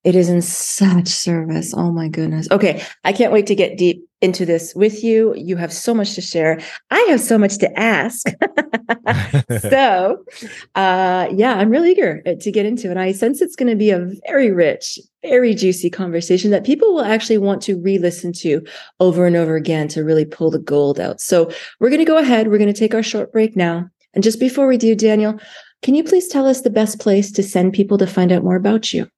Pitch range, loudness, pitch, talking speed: 175-230 Hz, -16 LUFS, 200 Hz, 220 wpm